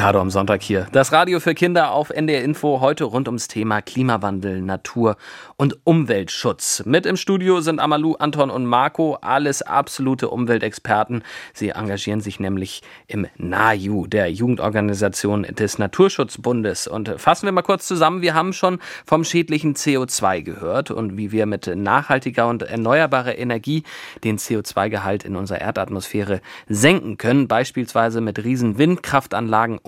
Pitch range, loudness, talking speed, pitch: 105-150 Hz, -19 LUFS, 145 wpm, 115 Hz